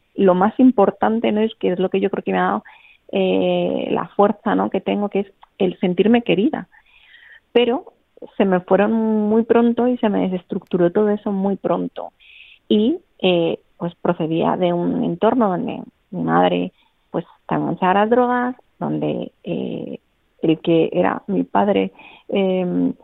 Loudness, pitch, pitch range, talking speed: -19 LUFS, 195 Hz, 165-220 Hz, 160 wpm